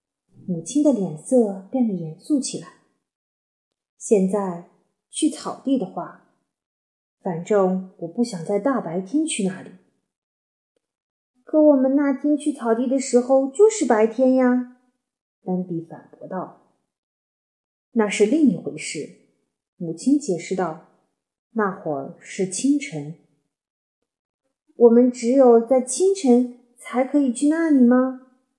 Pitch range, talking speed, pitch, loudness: 185-265 Hz, 170 characters per minute, 245 Hz, -20 LUFS